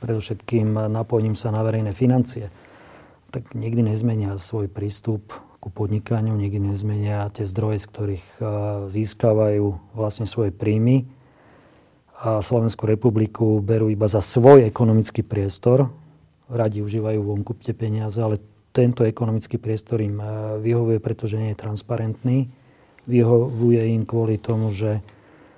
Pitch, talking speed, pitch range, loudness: 110 Hz, 125 wpm, 105-115 Hz, -21 LUFS